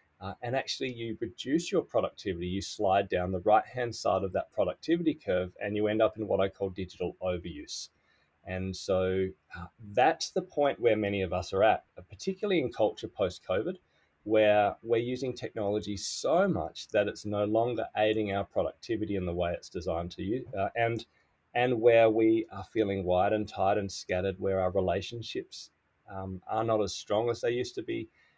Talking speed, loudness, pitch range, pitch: 190 wpm, -30 LUFS, 95-115 Hz, 105 Hz